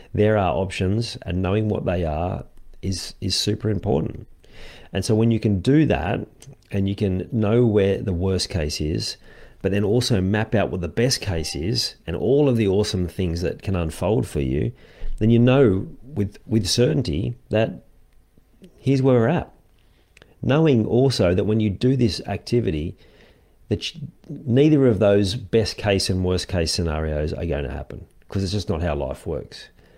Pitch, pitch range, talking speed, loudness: 100 Hz, 90-120 Hz, 180 wpm, -22 LUFS